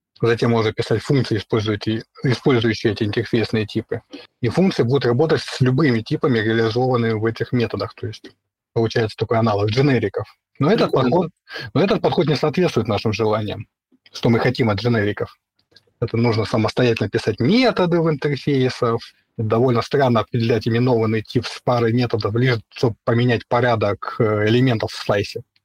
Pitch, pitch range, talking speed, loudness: 115 Hz, 110-125 Hz, 145 wpm, -19 LUFS